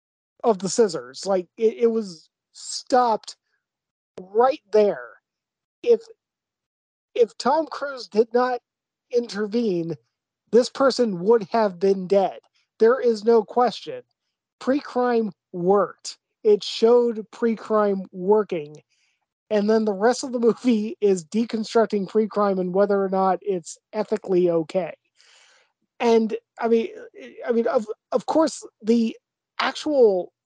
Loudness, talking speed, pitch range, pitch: -22 LUFS, 120 wpm, 200-245 Hz, 225 Hz